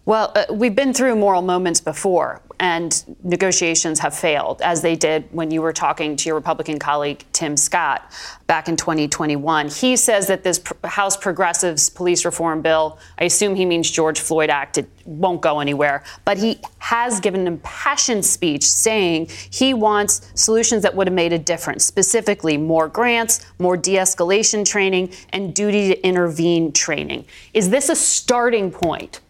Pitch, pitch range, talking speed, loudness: 175 Hz, 160-205 Hz, 170 wpm, -18 LUFS